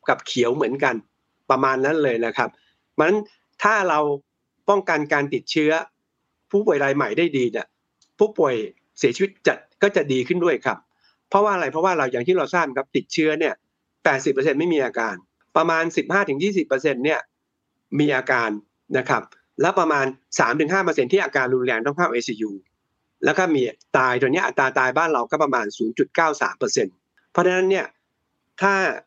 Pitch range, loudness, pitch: 135-195 Hz, -21 LUFS, 160 Hz